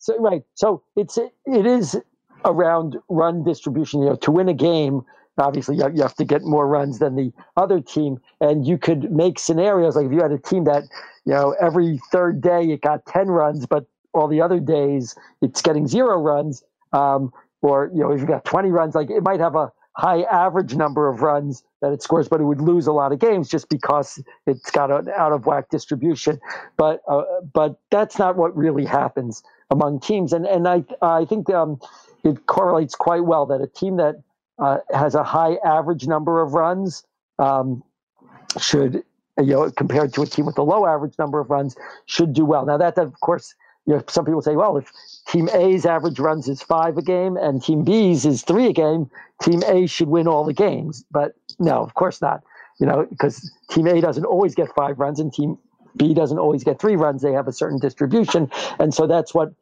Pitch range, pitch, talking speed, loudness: 145-170 Hz, 155 Hz, 215 wpm, -19 LUFS